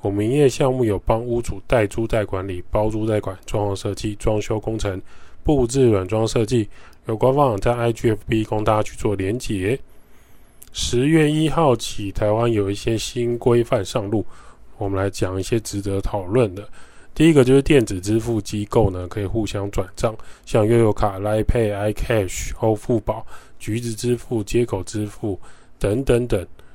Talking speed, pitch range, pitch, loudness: 270 characters per minute, 100-120 Hz, 110 Hz, -21 LUFS